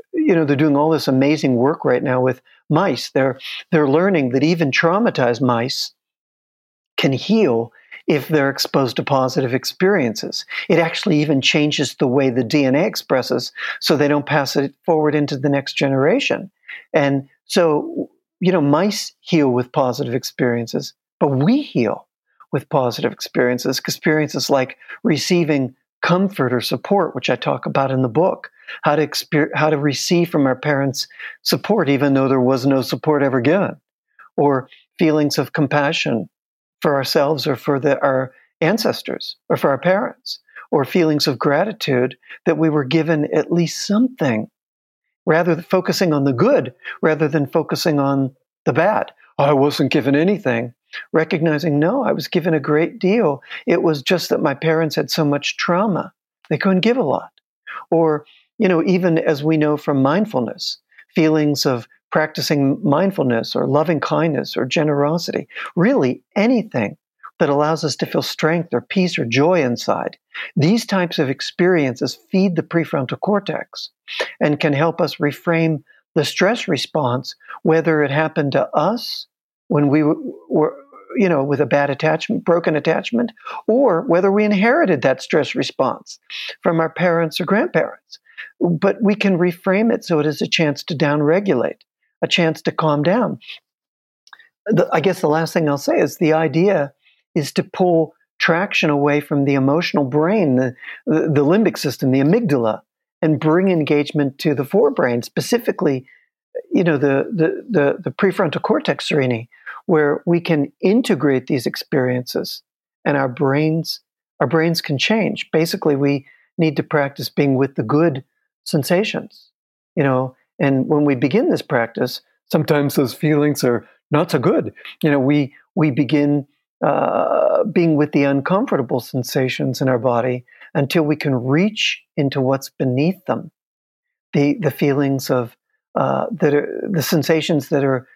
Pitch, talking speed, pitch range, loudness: 150 Hz, 160 wpm, 140-170 Hz, -18 LUFS